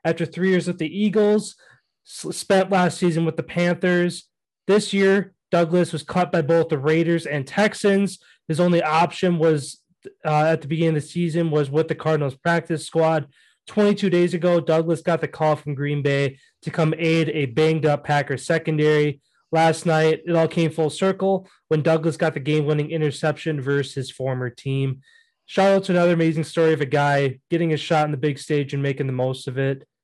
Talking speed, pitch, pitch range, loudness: 195 wpm, 160 Hz, 150-175 Hz, -21 LUFS